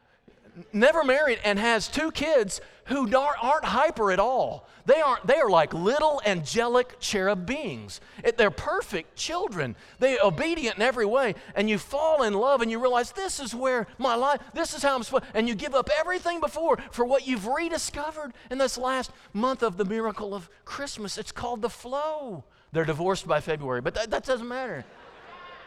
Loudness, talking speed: -26 LUFS, 185 wpm